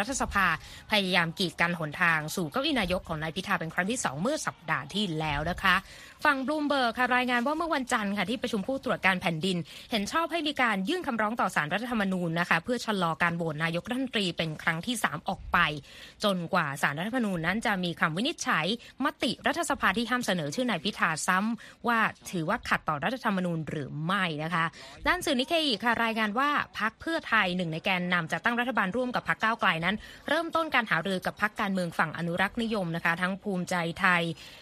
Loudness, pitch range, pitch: -28 LUFS, 170-245 Hz, 200 Hz